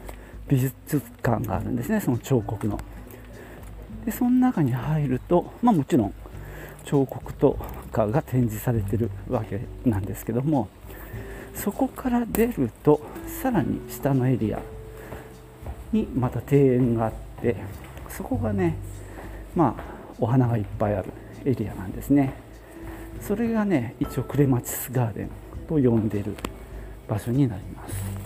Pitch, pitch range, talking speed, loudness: 120 Hz, 105-135 Hz, 260 characters per minute, -25 LUFS